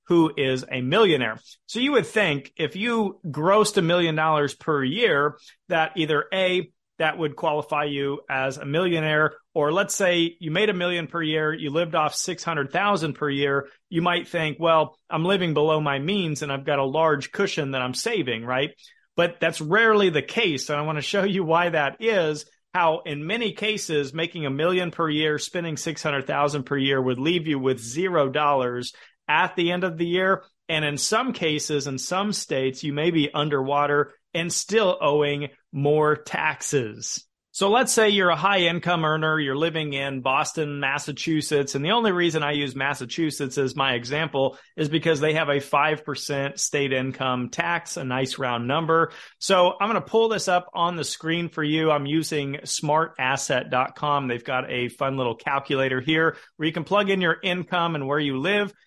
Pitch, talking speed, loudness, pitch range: 155 Hz, 190 wpm, -23 LUFS, 140-175 Hz